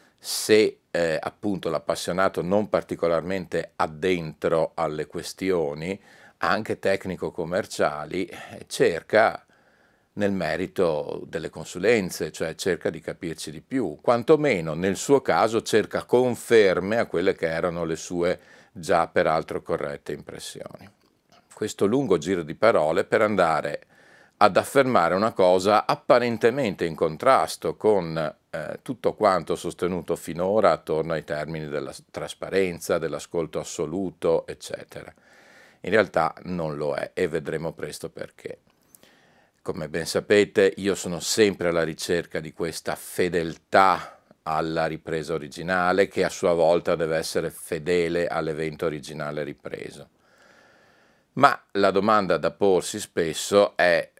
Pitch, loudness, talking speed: 100 Hz, -24 LUFS, 115 wpm